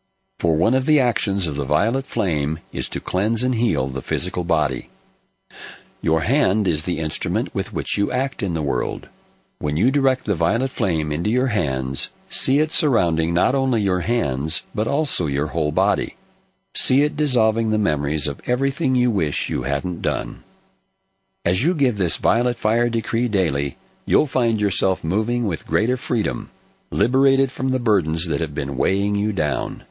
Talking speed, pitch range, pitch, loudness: 175 wpm, 80-125 Hz, 110 Hz, -21 LUFS